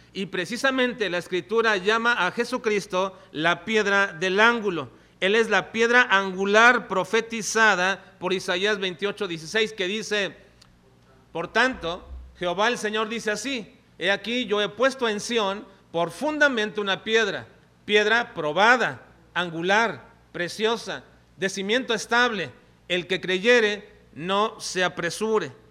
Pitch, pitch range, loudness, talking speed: 205 Hz, 185-225 Hz, -23 LUFS, 125 wpm